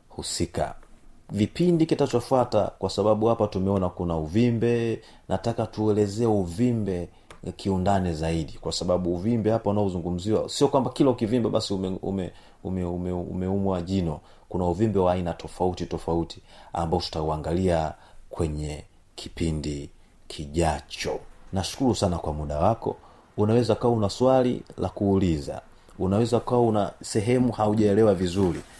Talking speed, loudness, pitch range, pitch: 115 wpm, -25 LUFS, 85-110 Hz, 95 Hz